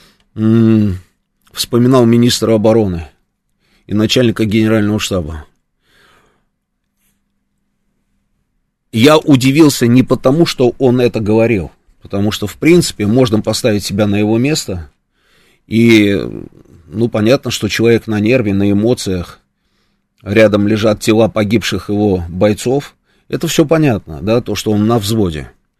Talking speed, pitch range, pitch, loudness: 115 wpm, 100-120 Hz, 110 Hz, -12 LUFS